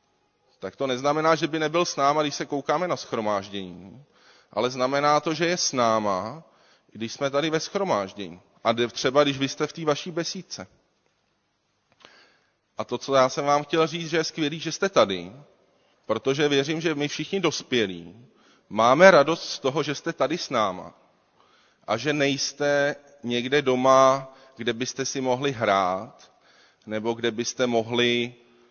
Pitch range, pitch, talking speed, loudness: 120-155 Hz, 140 Hz, 160 wpm, -24 LUFS